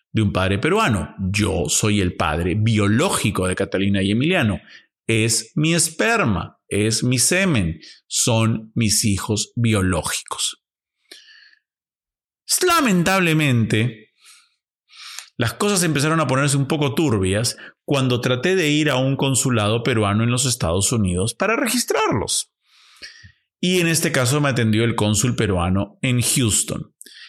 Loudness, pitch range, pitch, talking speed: -19 LUFS, 105-150 Hz, 115 Hz, 125 wpm